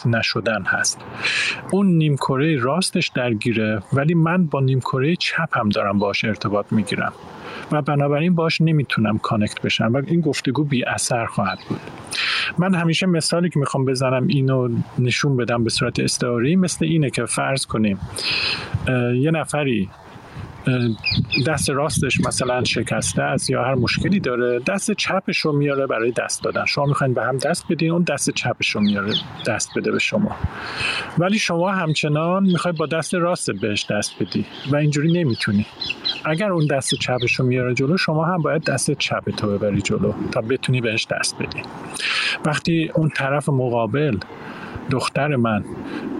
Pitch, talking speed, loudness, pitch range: 140 Hz, 155 wpm, -20 LUFS, 120-160 Hz